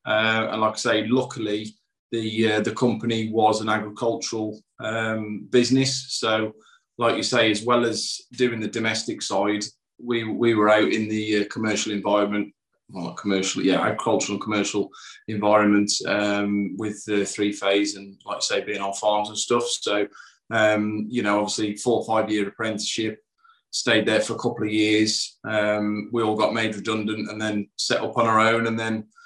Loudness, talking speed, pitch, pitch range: -23 LUFS, 180 wpm, 110 Hz, 105-115 Hz